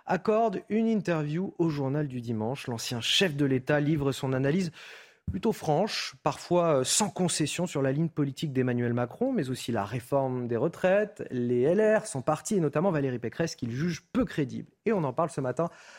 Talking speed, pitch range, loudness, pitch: 185 wpm, 130-180 Hz, -28 LUFS, 155 Hz